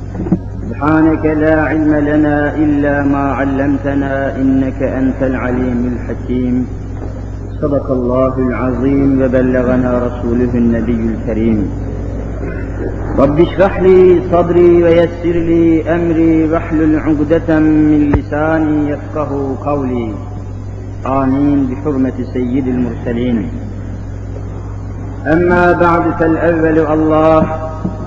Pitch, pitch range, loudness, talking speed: 135 Hz, 115-155 Hz, -13 LUFS, 85 wpm